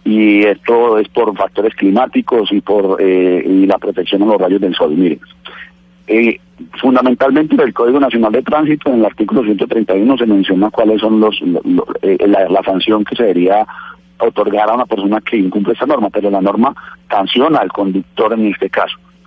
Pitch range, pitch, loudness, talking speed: 100-125 Hz, 110 Hz, -12 LUFS, 200 wpm